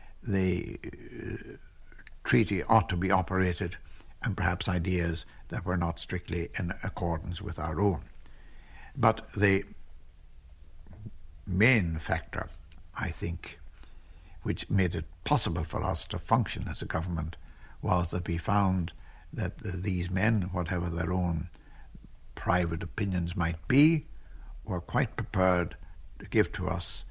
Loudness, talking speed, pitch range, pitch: -30 LUFS, 130 wpm, 80-95 Hz, 90 Hz